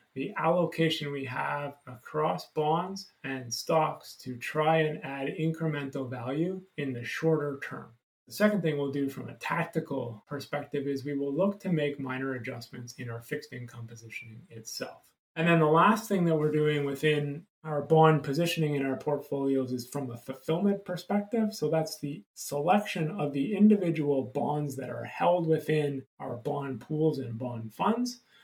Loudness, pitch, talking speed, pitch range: -30 LUFS, 145 Hz, 165 wpm, 135-160 Hz